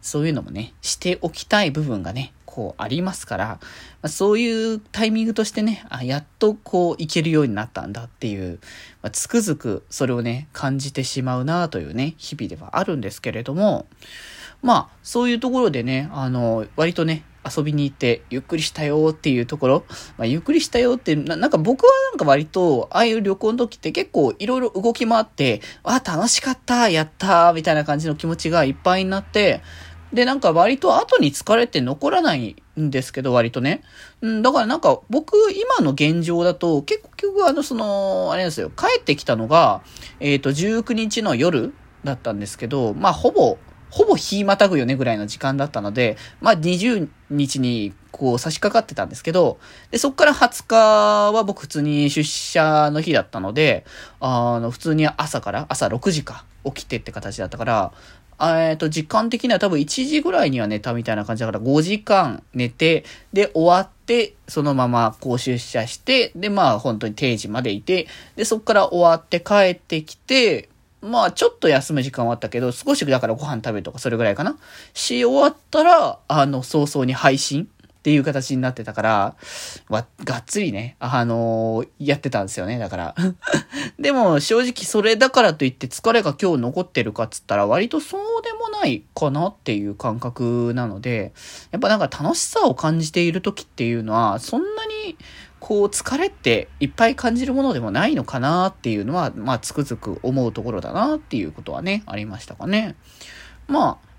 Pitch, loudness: 155 Hz, -20 LUFS